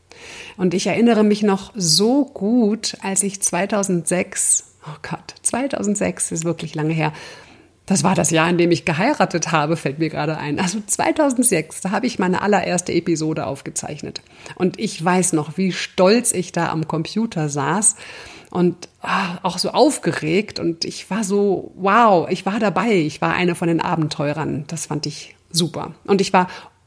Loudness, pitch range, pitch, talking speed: -19 LUFS, 165-205 Hz, 185 Hz, 170 wpm